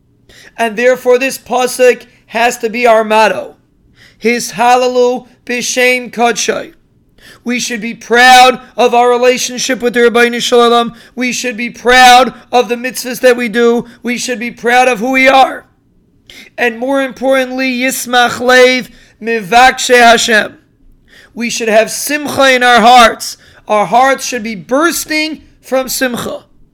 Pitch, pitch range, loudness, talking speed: 245 Hz, 235-255 Hz, -10 LUFS, 135 wpm